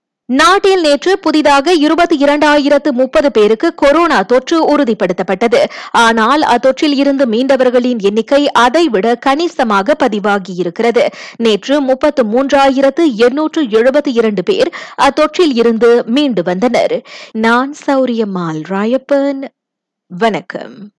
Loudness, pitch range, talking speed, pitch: -11 LUFS, 230-295 Hz, 85 wpm, 265 Hz